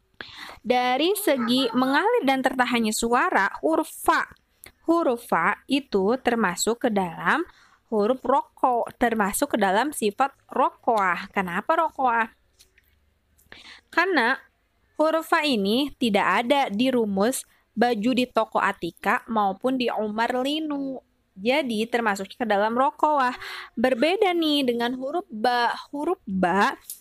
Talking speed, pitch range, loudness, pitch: 115 wpm, 220-285 Hz, -23 LUFS, 250 Hz